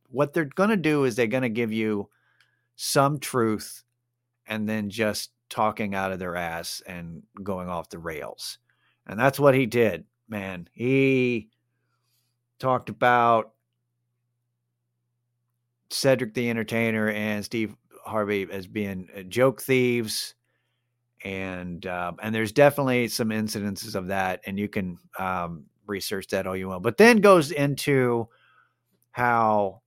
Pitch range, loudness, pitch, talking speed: 100-125 Hz, -25 LUFS, 115 Hz, 135 wpm